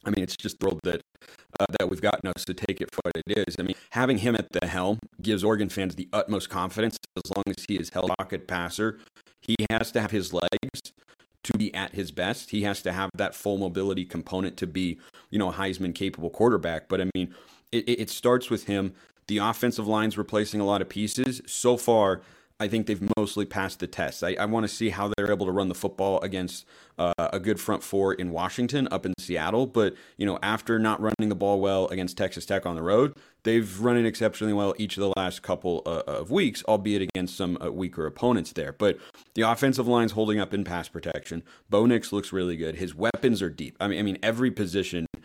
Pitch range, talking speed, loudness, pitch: 95-110 Hz, 230 wpm, -27 LUFS, 100 Hz